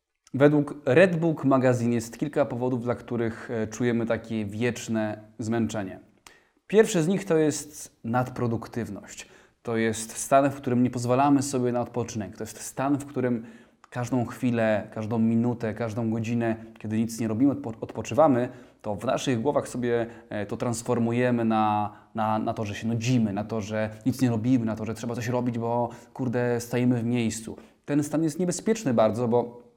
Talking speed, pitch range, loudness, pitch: 165 wpm, 115-125 Hz, -26 LUFS, 120 Hz